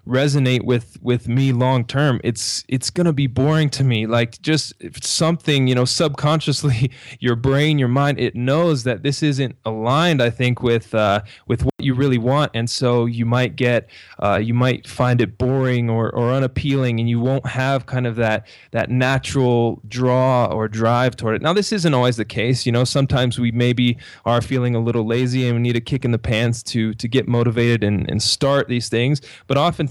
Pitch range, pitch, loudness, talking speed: 120-135 Hz, 125 Hz, -19 LUFS, 205 wpm